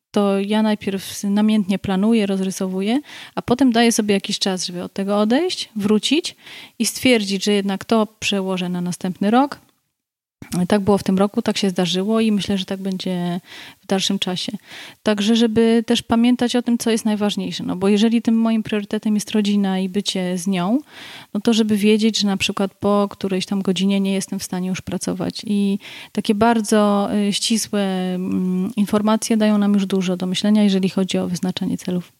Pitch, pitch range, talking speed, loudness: 205 Hz, 195-225 Hz, 180 wpm, -19 LUFS